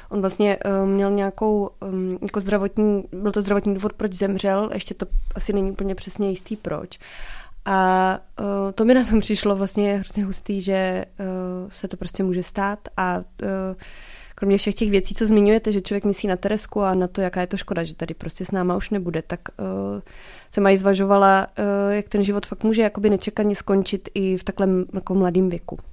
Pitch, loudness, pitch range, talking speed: 195 Hz, -22 LUFS, 190-205 Hz, 195 wpm